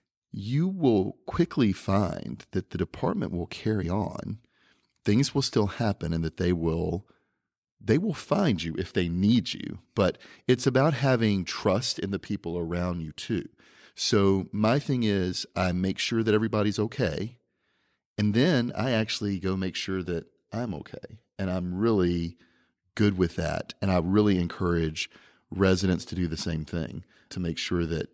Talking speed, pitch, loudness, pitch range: 165 wpm, 95 Hz, -27 LUFS, 85-110 Hz